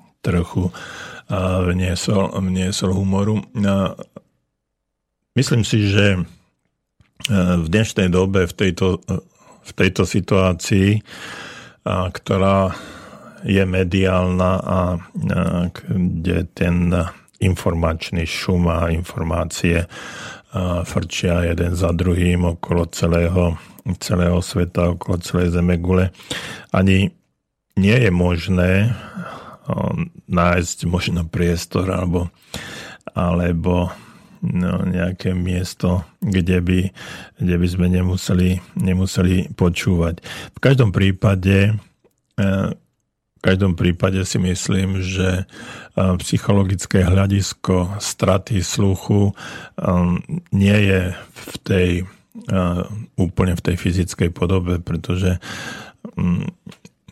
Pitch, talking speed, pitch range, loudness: 90 Hz, 85 wpm, 90-95 Hz, -19 LUFS